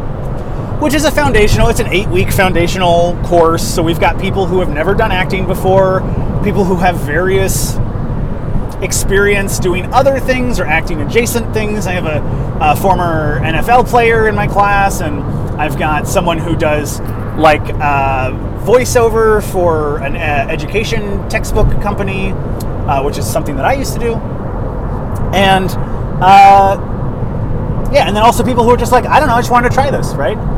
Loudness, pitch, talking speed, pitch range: -12 LUFS, 135 Hz, 170 wpm, 115-185 Hz